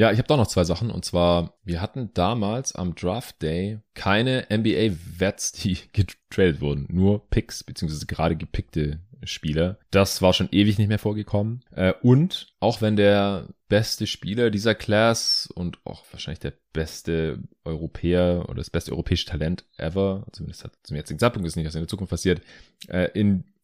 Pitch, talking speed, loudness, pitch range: 95 Hz, 175 wpm, -24 LUFS, 85-110 Hz